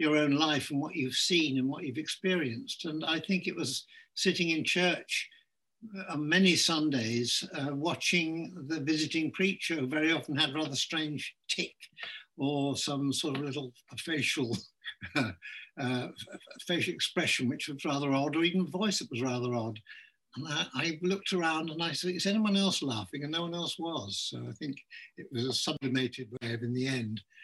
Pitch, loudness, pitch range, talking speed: 155 Hz, -31 LUFS, 135-170 Hz, 180 wpm